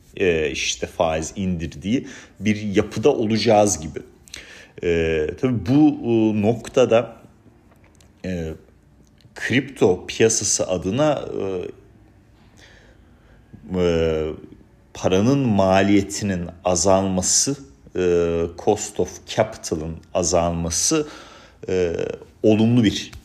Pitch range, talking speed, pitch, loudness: 85-110 Hz, 70 wpm, 95 Hz, -20 LUFS